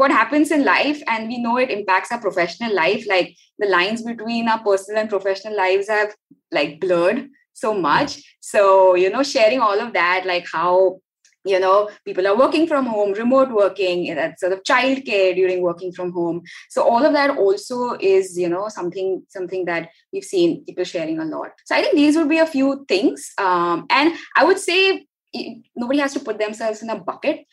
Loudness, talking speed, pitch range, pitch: -19 LUFS, 200 wpm, 185-275 Hz, 210 Hz